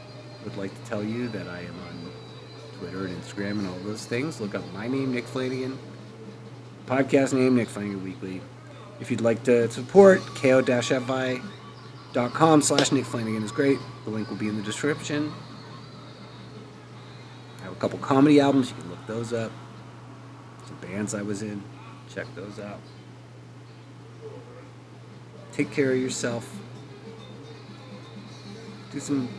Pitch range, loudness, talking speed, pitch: 105-135 Hz, -25 LUFS, 145 wpm, 120 Hz